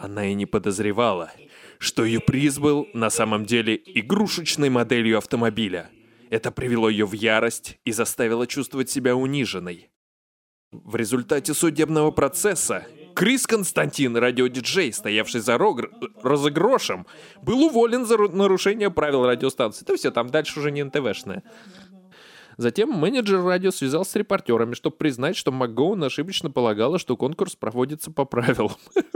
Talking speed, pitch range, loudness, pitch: 135 wpm, 115-175 Hz, -22 LUFS, 135 Hz